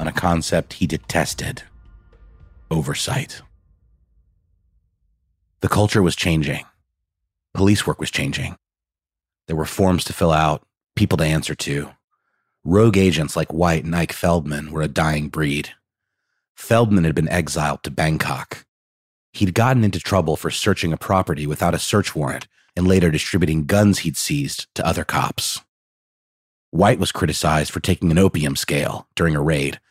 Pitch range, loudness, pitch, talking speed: 75-95 Hz, -20 LUFS, 85 Hz, 145 wpm